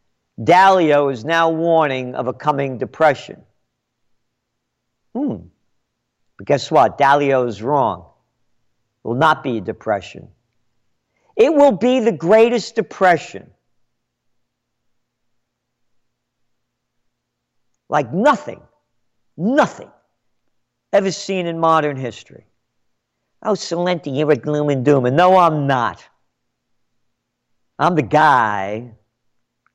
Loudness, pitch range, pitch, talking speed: -16 LUFS, 130-185 Hz, 150 Hz, 100 wpm